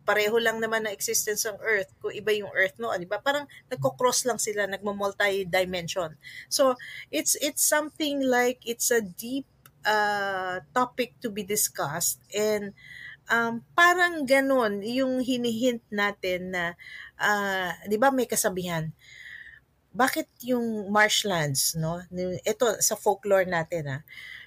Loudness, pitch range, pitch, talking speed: -26 LUFS, 185-245 Hz, 210 Hz, 135 wpm